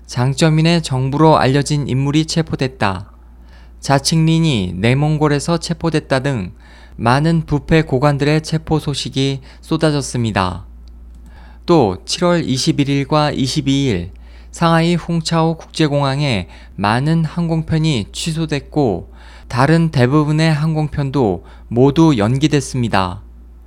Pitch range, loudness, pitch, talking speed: 105-160 Hz, -16 LUFS, 140 Hz, 240 characters per minute